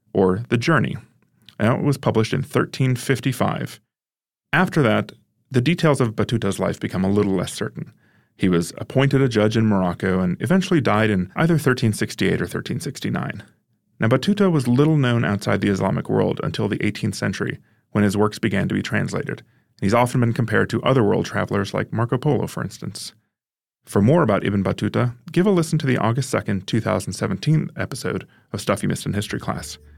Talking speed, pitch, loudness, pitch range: 180 wpm, 115 Hz, -21 LUFS, 100-135 Hz